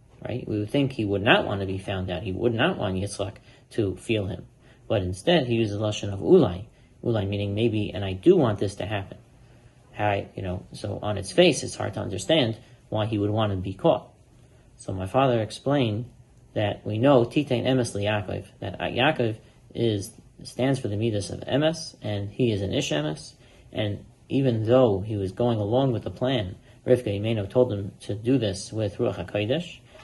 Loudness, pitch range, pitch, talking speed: -25 LUFS, 100-125 Hz, 110 Hz, 200 wpm